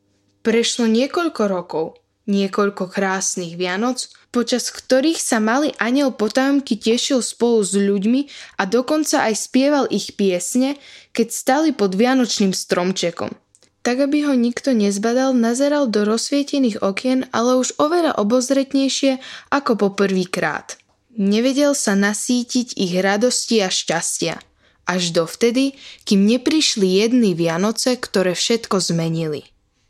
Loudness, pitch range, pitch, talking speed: -18 LUFS, 200-260 Hz, 230 Hz, 120 wpm